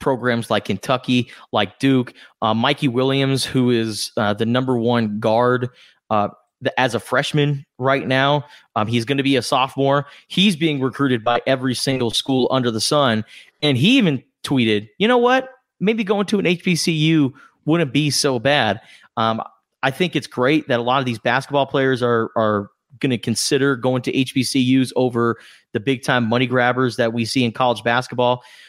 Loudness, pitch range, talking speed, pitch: -19 LUFS, 120-145 Hz, 180 wpm, 130 Hz